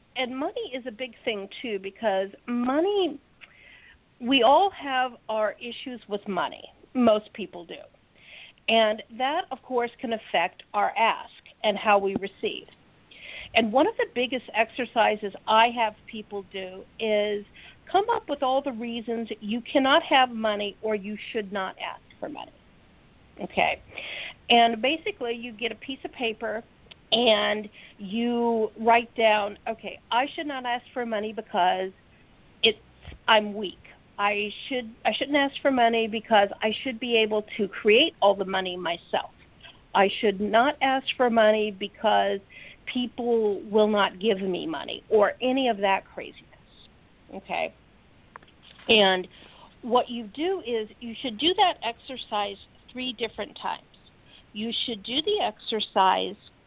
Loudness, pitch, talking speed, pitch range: -25 LUFS, 230 Hz, 145 wpm, 210-255 Hz